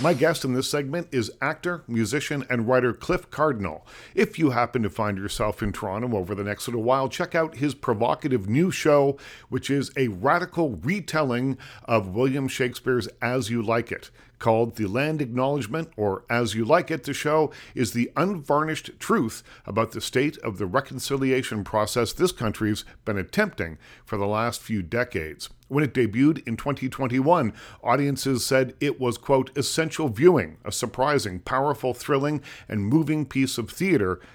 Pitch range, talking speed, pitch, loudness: 115-150 Hz, 165 wpm, 130 Hz, -25 LUFS